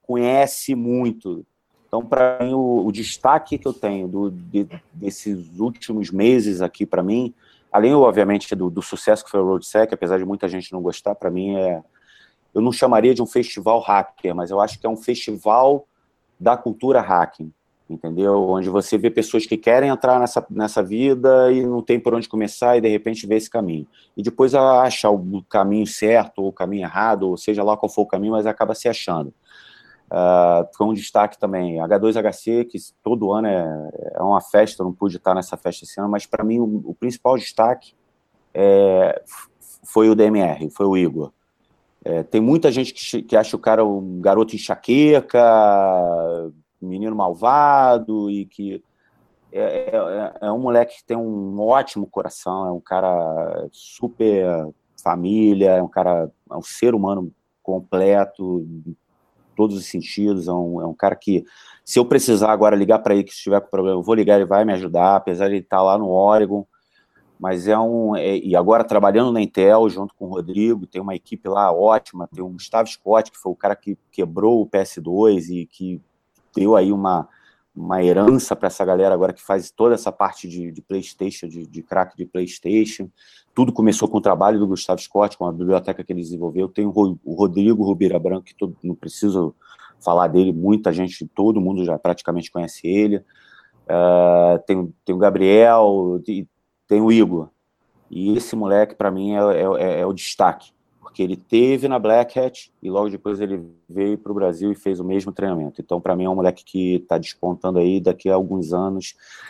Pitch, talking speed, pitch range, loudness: 100 Hz, 190 wpm, 90-110 Hz, -19 LUFS